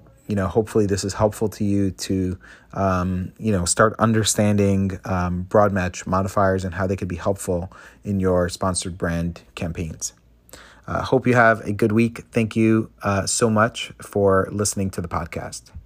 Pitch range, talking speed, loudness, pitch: 90-110 Hz, 180 wpm, -21 LUFS, 100 Hz